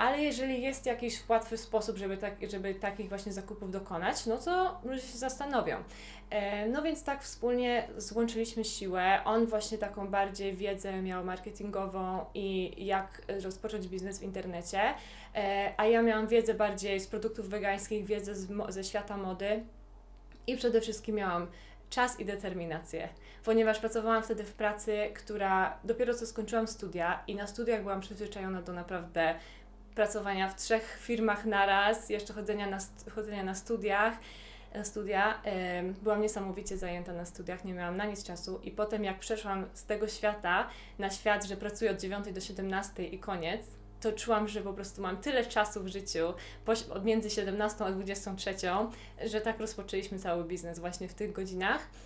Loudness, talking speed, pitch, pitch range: -34 LUFS, 160 wpm, 205 Hz, 195-220 Hz